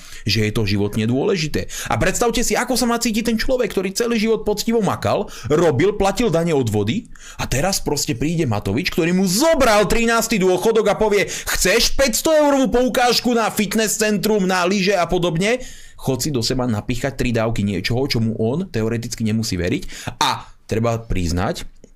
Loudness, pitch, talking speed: -19 LUFS, 180 Hz, 175 wpm